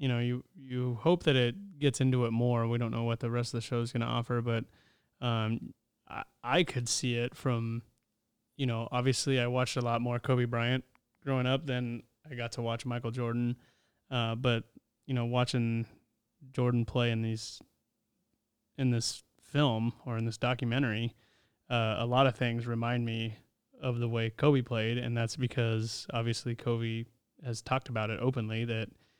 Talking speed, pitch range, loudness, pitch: 185 wpm, 115-125 Hz, -32 LUFS, 120 Hz